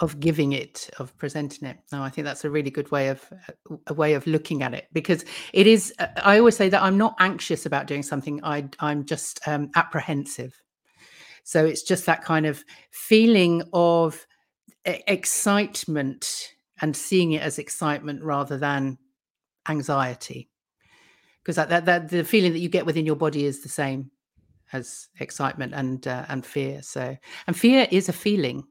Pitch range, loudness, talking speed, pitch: 140-175 Hz, -23 LUFS, 175 wpm, 155 Hz